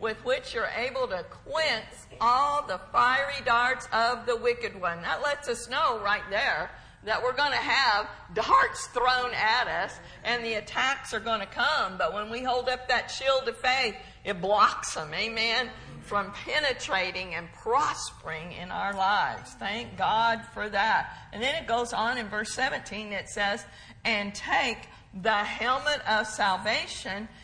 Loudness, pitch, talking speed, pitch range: -27 LUFS, 235 Hz, 165 wpm, 210-265 Hz